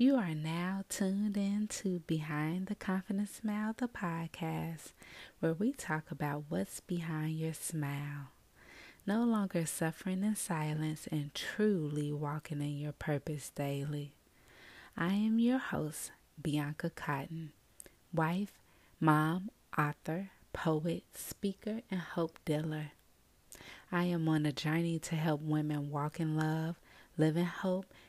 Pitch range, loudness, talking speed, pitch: 150-190 Hz, -36 LUFS, 130 wpm, 160 Hz